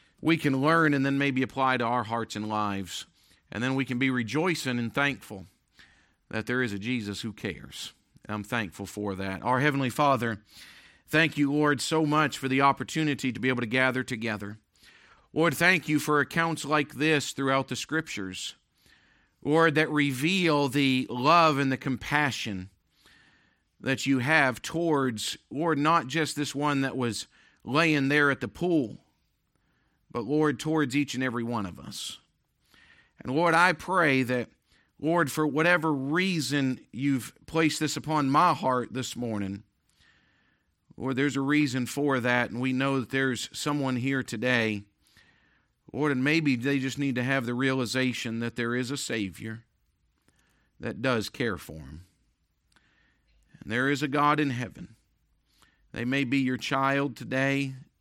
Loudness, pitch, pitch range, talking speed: -27 LUFS, 130 Hz, 115-145 Hz, 160 wpm